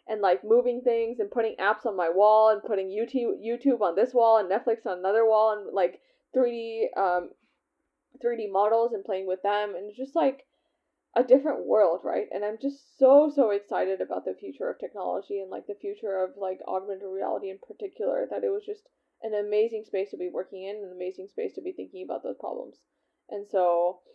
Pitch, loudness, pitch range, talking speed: 225 Hz, -27 LUFS, 200-300 Hz, 210 wpm